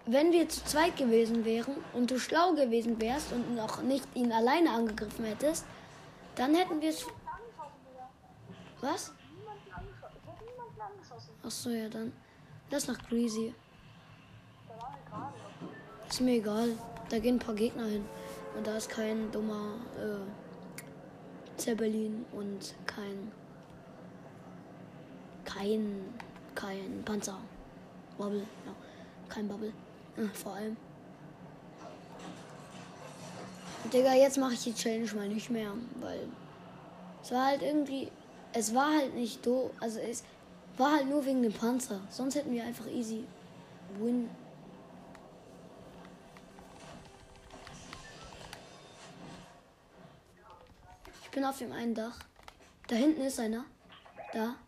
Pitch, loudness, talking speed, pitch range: 235 Hz, -33 LUFS, 110 wpm, 220-265 Hz